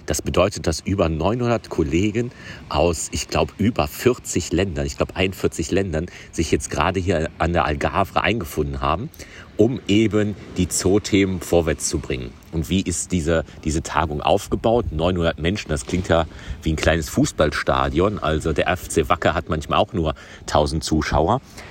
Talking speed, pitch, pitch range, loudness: 160 wpm, 85 Hz, 80-100 Hz, -21 LUFS